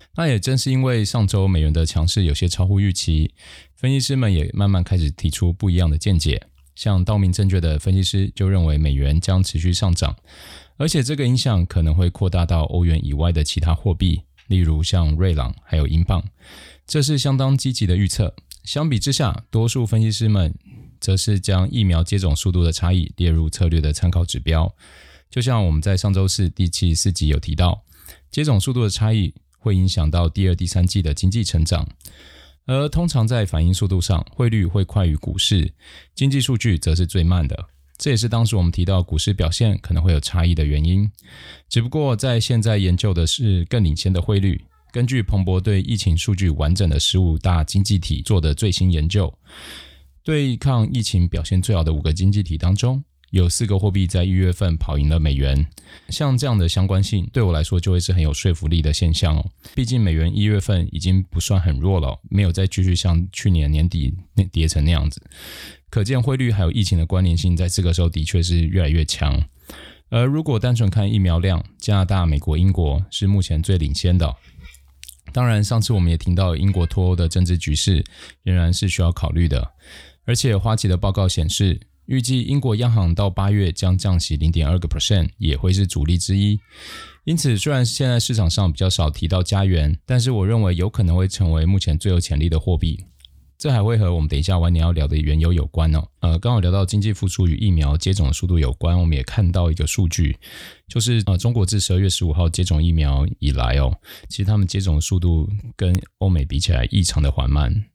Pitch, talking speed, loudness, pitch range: 90 Hz, 315 characters per minute, -19 LUFS, 80-105 Hz